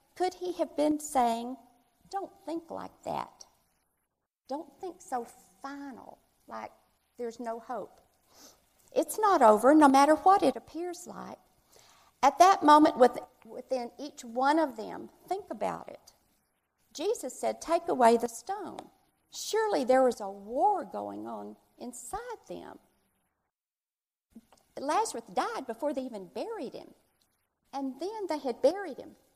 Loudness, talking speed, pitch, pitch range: -28 LUFS, 135 wpm, 280 Hz, 245-350 Hz